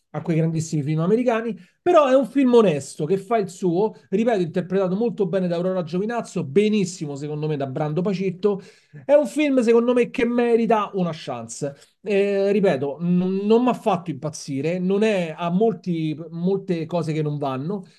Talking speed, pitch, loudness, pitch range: 175 wpm, 190 Hz, -22 LUFS, 160-220 Hz